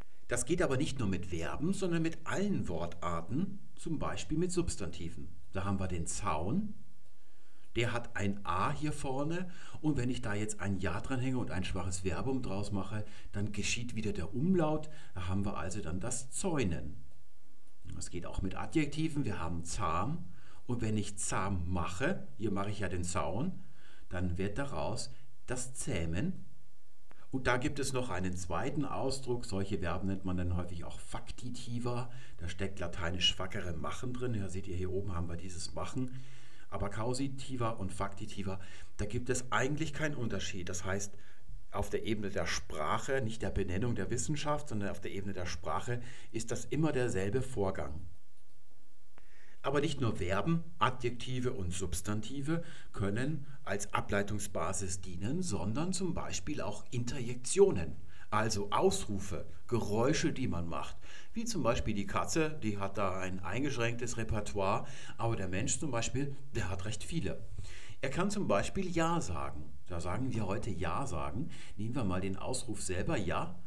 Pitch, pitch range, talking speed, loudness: 105 Hz, 95-130 Hz, 165 wpm, -37 LUFS